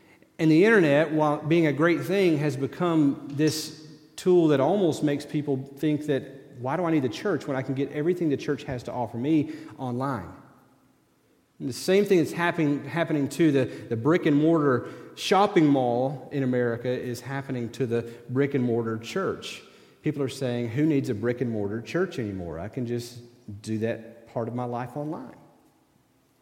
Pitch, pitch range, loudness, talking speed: 140 Hz, 120-155 Hz, -26 LUFS, 185 wpm